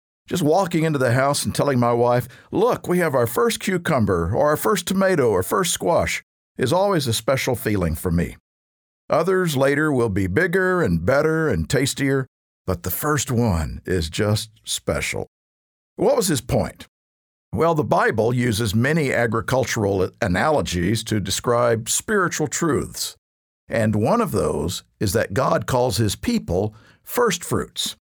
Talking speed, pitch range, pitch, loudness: 150 wpm, 95-150 Hz, 120 Hz, -21 LUFS